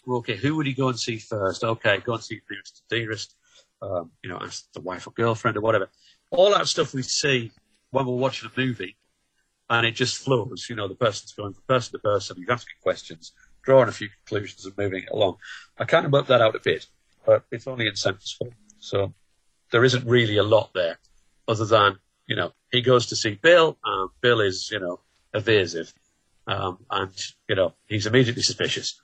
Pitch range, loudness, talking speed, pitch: 105-125 Hz, -23 LUFS, 215 wpm, 115 Hz